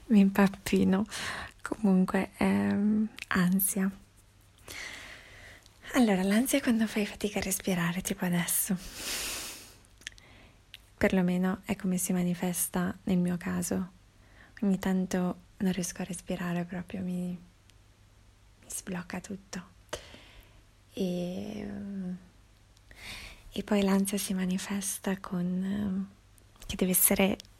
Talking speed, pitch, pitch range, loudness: 95 wpm, 185 Hz, 175-200 Hz, -30 LUFS